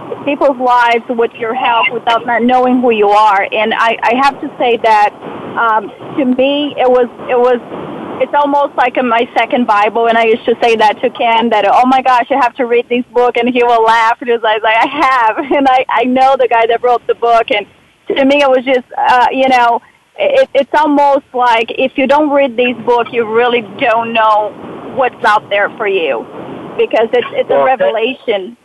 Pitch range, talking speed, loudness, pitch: 230-270 Hz, 215 wpm, -11 LUFS, 245 Hz